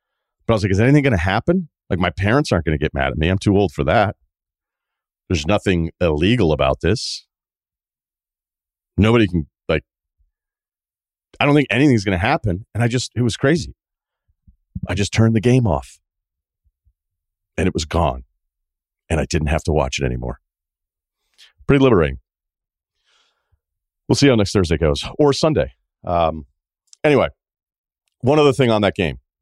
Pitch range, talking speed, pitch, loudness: 75-110 Hz, 155 wpm, 85 Hz, -18 LUFS